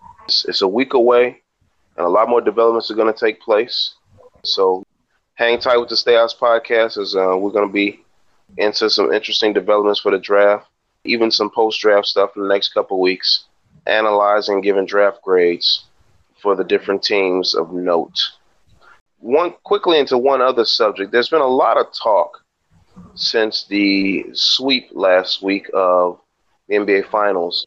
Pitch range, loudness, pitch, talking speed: 100-120 Hz, -16 LUFS, 105 Hz, 165 wpm